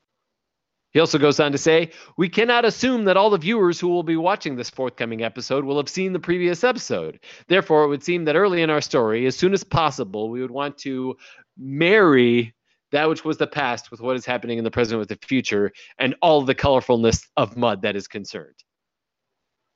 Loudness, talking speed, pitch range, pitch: -20 LUFS, 205 wpm, 120-175 Hz, 145 Hz